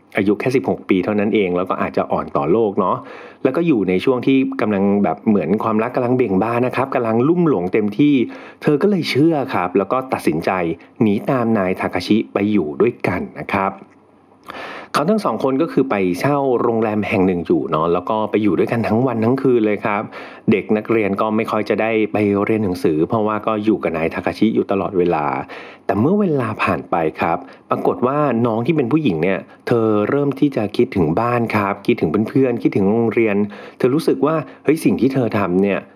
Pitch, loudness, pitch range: 110 Hz, -18 LUFS, 100-125 Hz